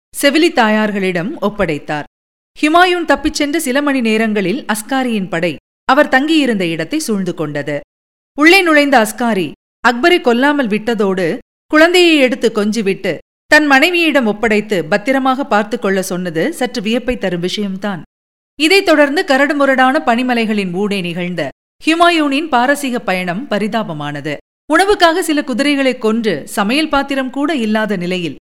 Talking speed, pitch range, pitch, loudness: 115 wpm, 205-290 Hz, 240 Hz, -13 LUFS